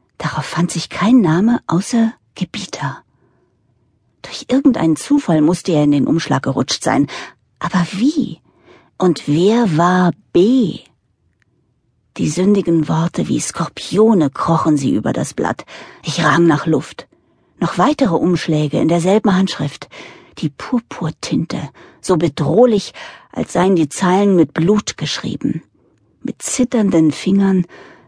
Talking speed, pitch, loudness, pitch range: 120 wpm, 170 Hz, -16 LUFS, 150-195 Hz